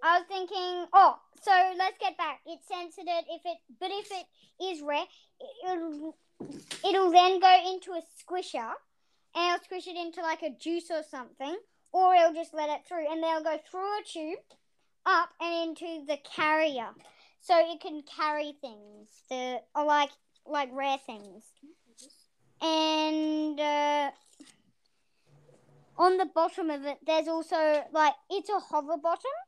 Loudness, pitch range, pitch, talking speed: -29 LUFS, 300-365 Hz, 330 Hz, 155 wpm